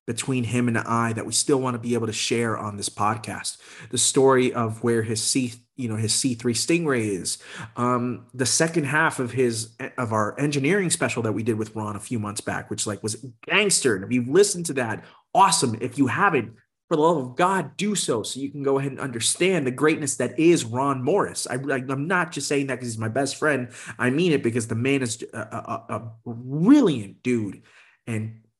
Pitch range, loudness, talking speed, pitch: 115-140 Hz, -23 LUFS, 225 wpm, 125 Hz